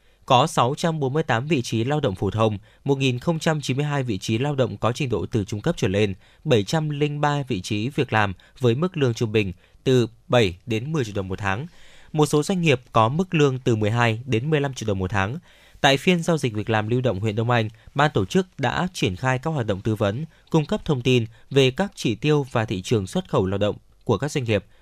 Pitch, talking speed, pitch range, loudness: 125 Hz, 230 wpm, 110-150 Hz, -23 LUFS